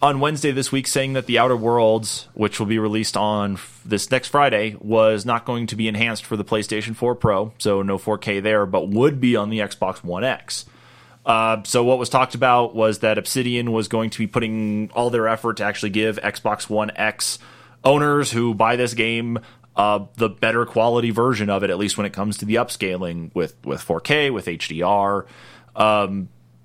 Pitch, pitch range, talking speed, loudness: 110 Hz, 105-120 Hz, 205 wpm, -20 LUFS